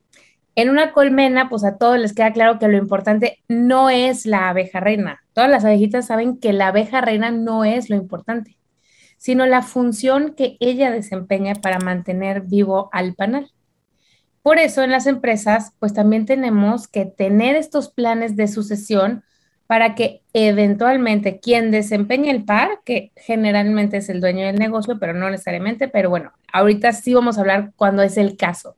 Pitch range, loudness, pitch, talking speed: 200-245 Hz, -17 LUFS, 220 Hz, 170 wpm